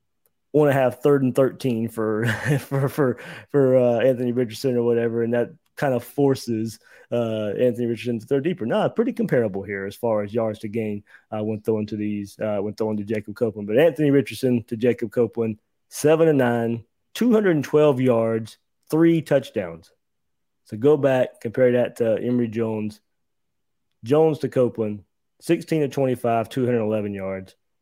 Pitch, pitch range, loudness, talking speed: 120 Hz, 110-135 Hz, -22 LUFS, 175 wpm